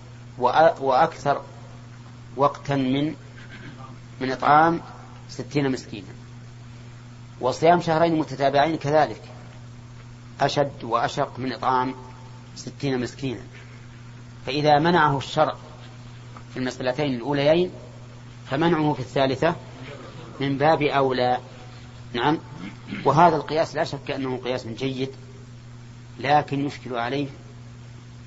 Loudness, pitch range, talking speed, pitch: -23 LUFS, 120-140 Hz, 85 wpm, 125 Hz